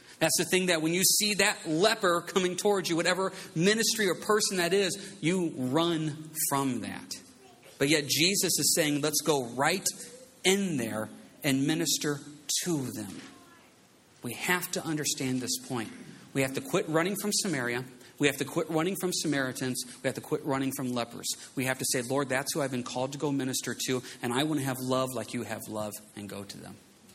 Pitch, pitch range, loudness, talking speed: 150 Hz, 130-180 Hz, -29 LUFS, 200 wpm